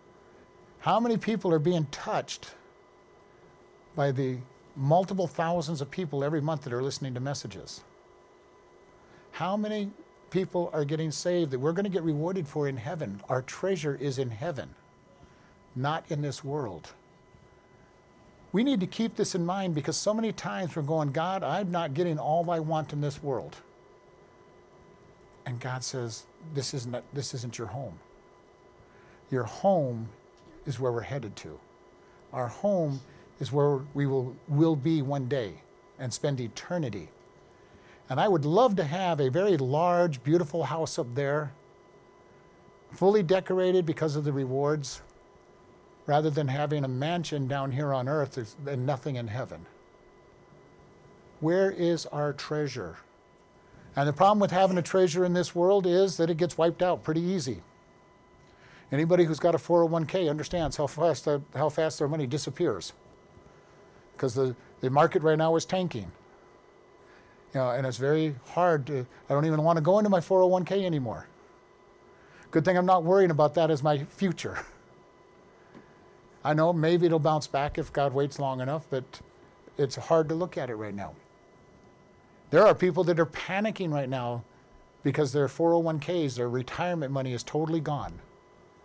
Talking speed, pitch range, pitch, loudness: 160 wpm, 135-175 Hz, 155 Hz, -28 LUFS